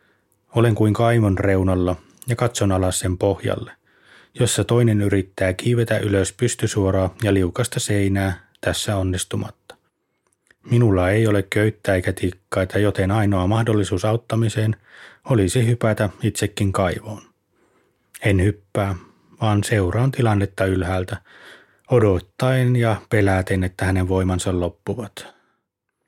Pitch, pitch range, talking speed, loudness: 100 Hz, 95-110 Hz, 110 wpm, -20 LUFS